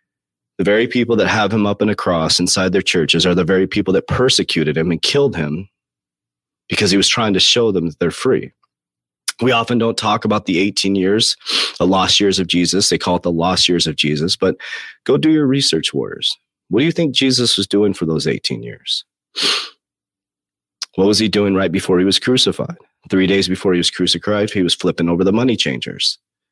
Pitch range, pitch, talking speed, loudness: 85-105 Hz, 95 Hz, 210 wpm, -15 LUFS